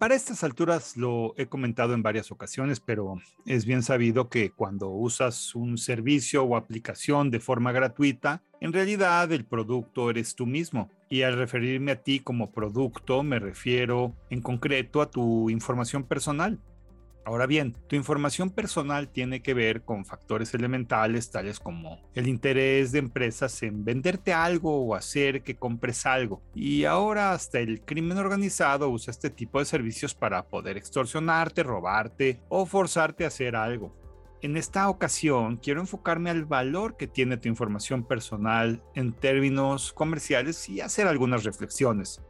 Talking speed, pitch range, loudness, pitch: 155 wpm, 115-145 Hz, -27 LUFS, 130 Hz